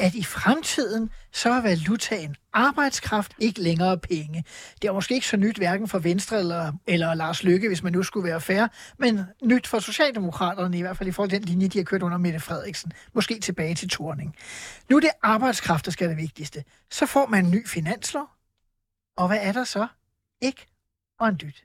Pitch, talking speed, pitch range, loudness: 190 Hz, 210 wpm, 170-220 Hz, -24 LUFS